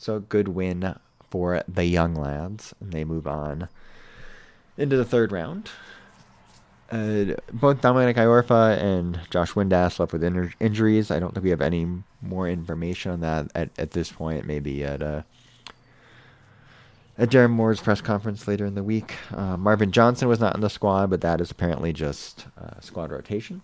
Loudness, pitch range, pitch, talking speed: -24 LUFS, 85-115 Hz, 100 Hz, 180 wpm